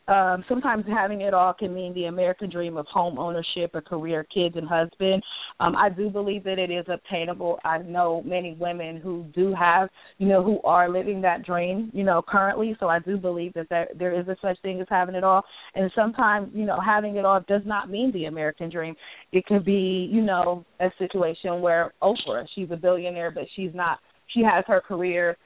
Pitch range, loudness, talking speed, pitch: 175-195 Hz, -25 LUFS, 210 wpm, 185 Hz